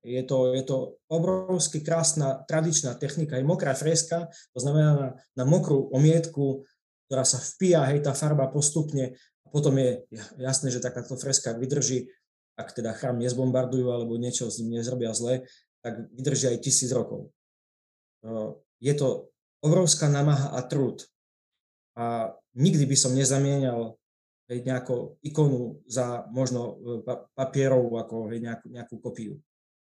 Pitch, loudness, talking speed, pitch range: 130 Hz, -26 LUFS, 135 wpm, 120-145 Hz